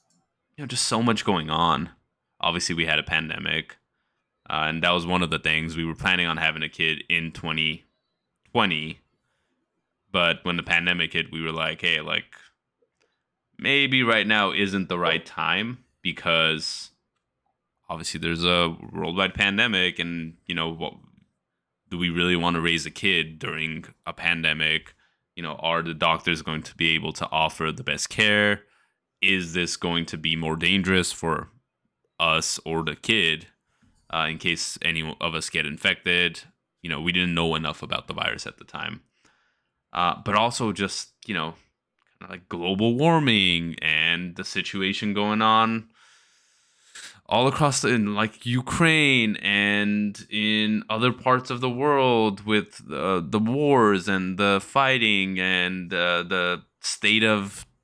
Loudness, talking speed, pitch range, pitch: -23 LUFS, 160 wpm, 80-105 Hz, 90 Hz